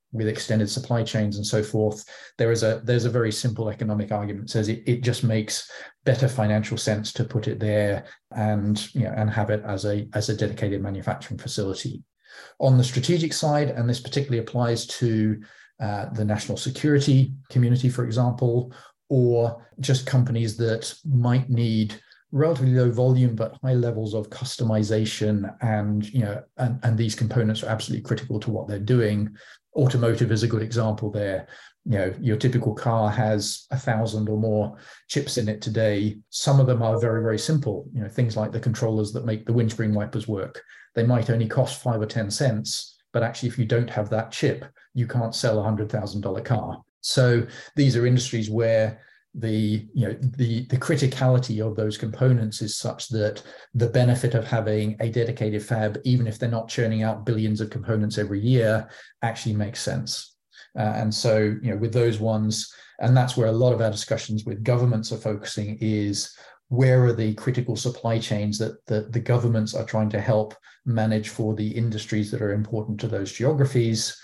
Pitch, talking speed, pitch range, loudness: 115 Hz, 185 wpm, 110-125 Hz, -24 LUFS